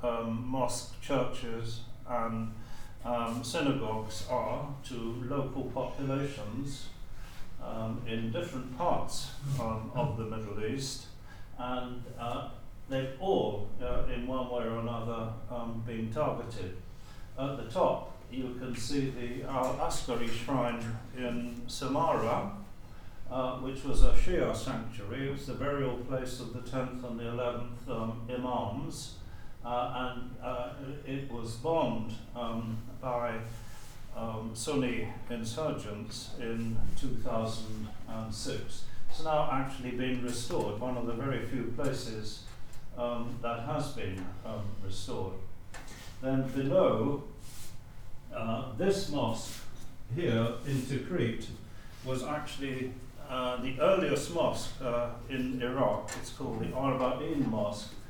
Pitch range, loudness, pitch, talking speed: 115-130 Hz, -35 LUFS, 120 Hz, 120 wpm